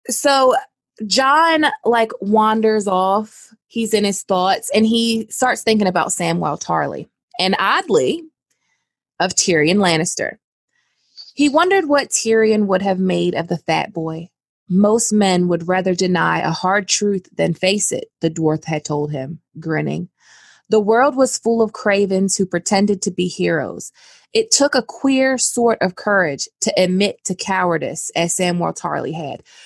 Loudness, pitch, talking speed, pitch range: -17 LUFS, 200 Hz, 150 wpm, 180-230 Hz